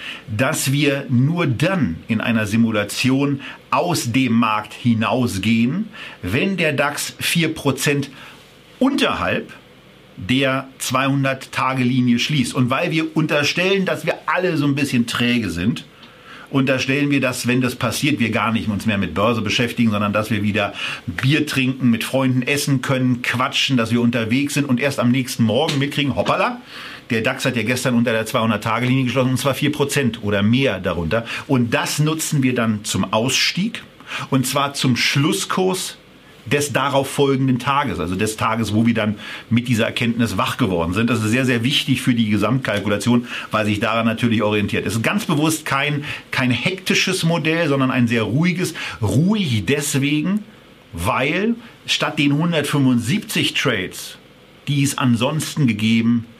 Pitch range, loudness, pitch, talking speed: 115-145 Hz, -19 LUFS, 130 Hz, 155 wpm